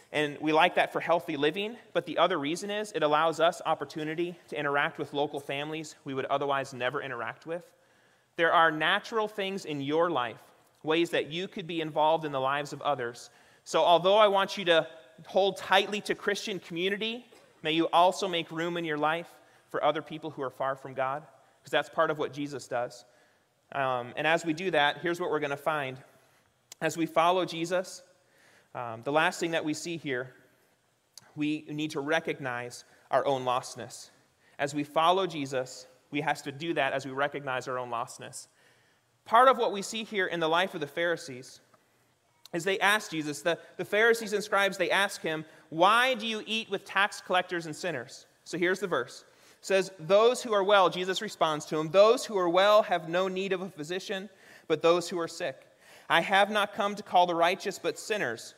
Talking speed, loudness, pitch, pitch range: 200 wpm, -28 LUFS, 165 Hz, 145-190 Hz